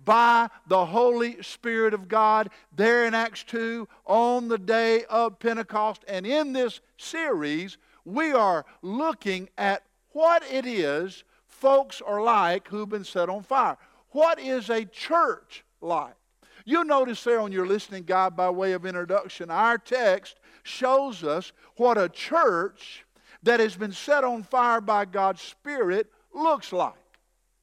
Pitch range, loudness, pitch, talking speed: 195-265 Hz, -25 LUFS, 230 Hz, 150 wpm